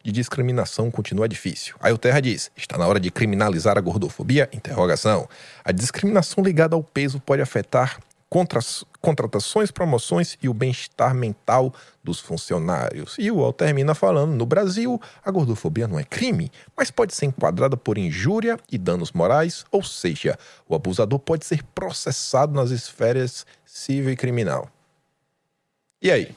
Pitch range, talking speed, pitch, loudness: 120-165 Hz, 150 wpm, 135 Hz, -22 LUFS